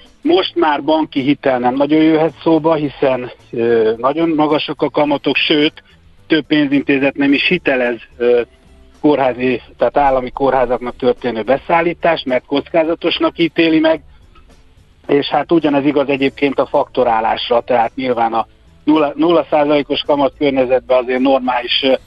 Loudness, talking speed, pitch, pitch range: -15 LUFS, 130 wpm, 140 Hz, 125-155 Hz